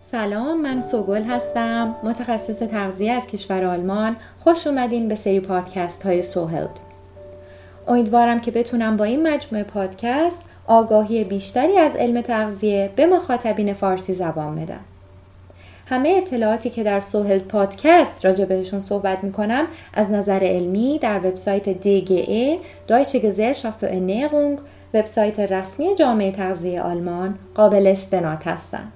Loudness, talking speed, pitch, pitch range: -20 LUFS, 130 wpm, 210 Hz, 190-235 Hz